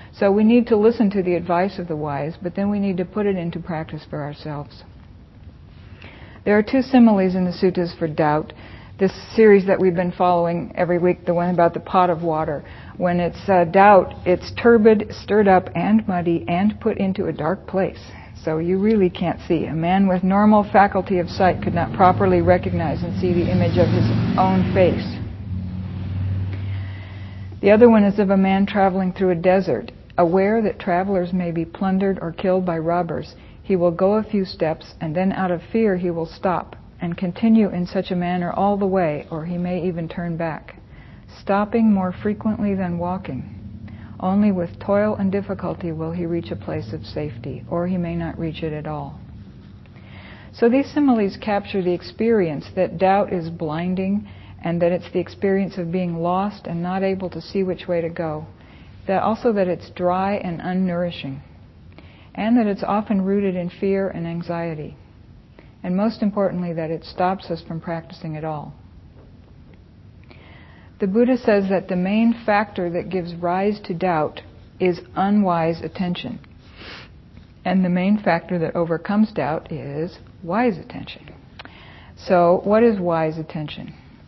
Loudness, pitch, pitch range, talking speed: -20 LUFS, 180 Hz, 165-195 Hz, 175 wpm